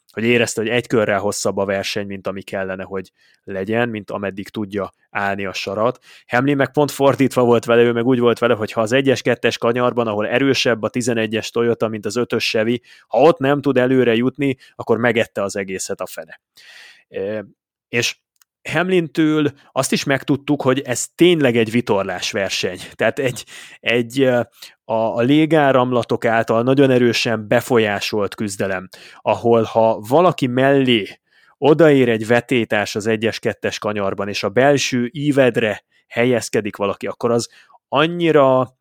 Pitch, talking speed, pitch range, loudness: 120 Hz, 150 wpm, 110-135 Hz, -18 LUFS